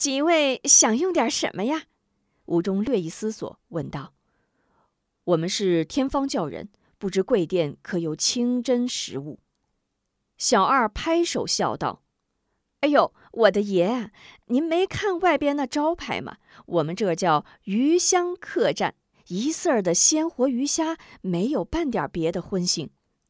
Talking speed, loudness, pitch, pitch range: 195 characters per minute, -23 LUFS, 250 Hz, 190-315 Hz